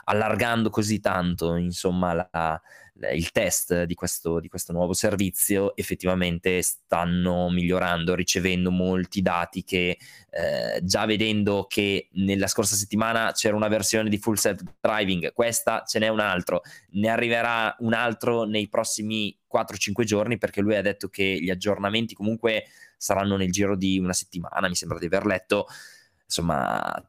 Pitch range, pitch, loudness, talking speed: 90-110 Hz, 100 Hz, -25 LUFS, 150 wpm